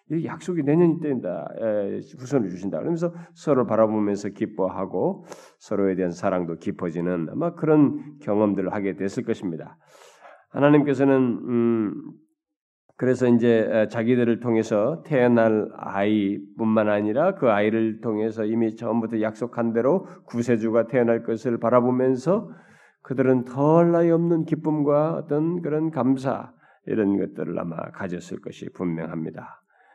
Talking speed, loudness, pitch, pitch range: 305 characters per minute, -23 LUFS, 120 Hz, 105-150 Hz